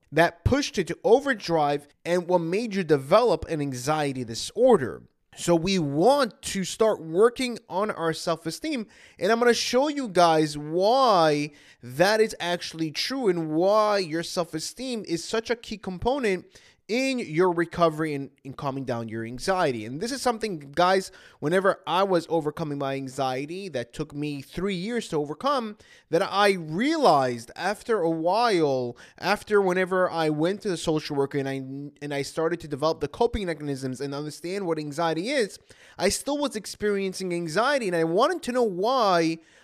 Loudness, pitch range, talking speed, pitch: -25 LUFS, 150-210 Hz, 170 wpm, 170 Hz